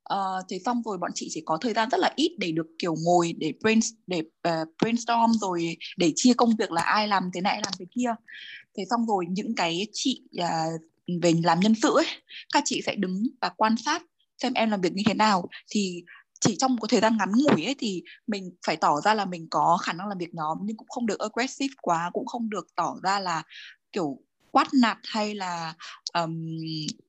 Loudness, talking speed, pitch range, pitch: -26 LUFS, 225 wpm, 175-235 Hz, 205 Hz